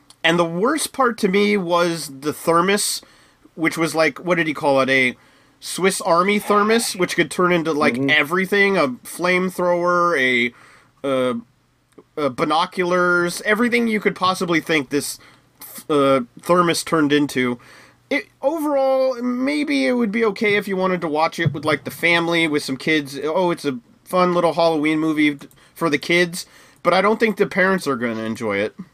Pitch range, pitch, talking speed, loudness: 150-200 Hz, 170 Hz, 175 wpm, -19 LUFS